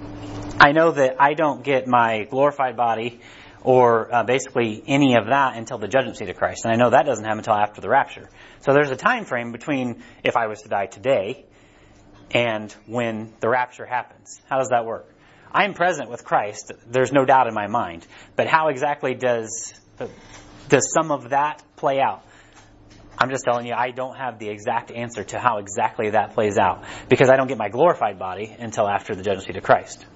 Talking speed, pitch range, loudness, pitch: 205 wpm, 105-130 Hz, -21 LUFS, 120 Hz